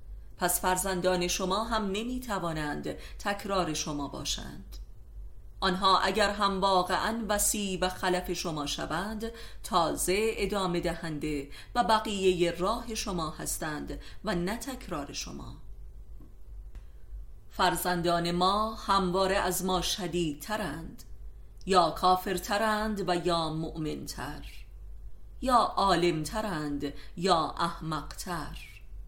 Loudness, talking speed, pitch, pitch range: -30 LUFS, 95 wpm, 185 Hz, 170-205 Hz